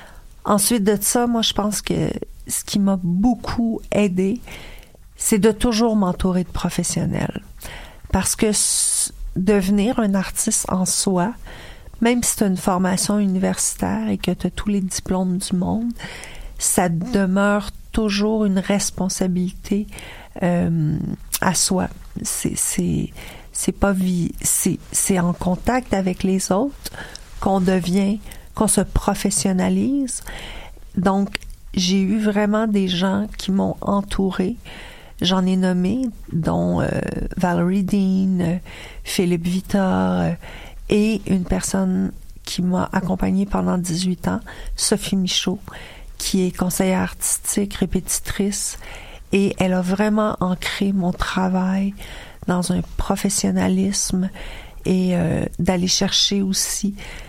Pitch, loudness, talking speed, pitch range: 190 Hz, -20 LUFS, 120 wpm, 180-205 Hz